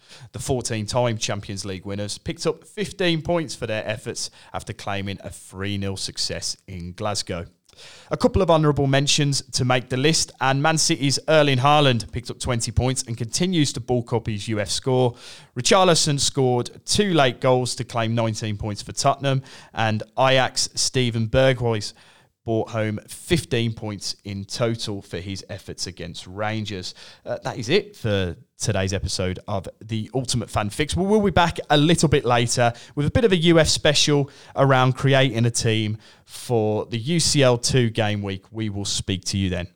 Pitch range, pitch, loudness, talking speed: 105-135 Hz, 120 Hz, -22 LUFS, 170 wpm